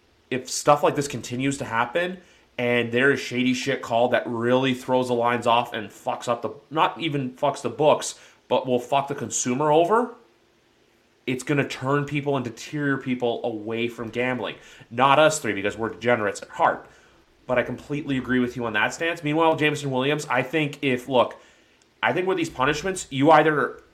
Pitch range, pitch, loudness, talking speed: 120-150 Hz, 130 Hz, -23 LUFS, 190 wpm